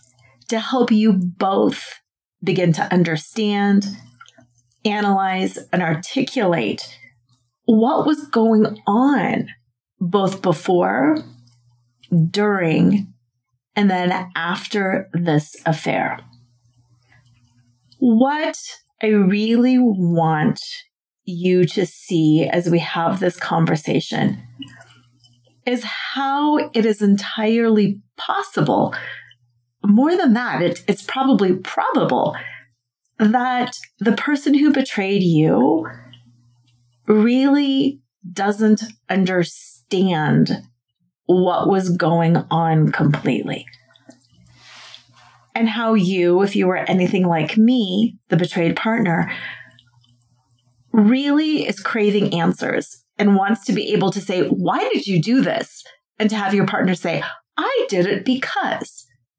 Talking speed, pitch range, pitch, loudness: 100 wpm, 135-220 Hz, 185 Hz, -18 LUFS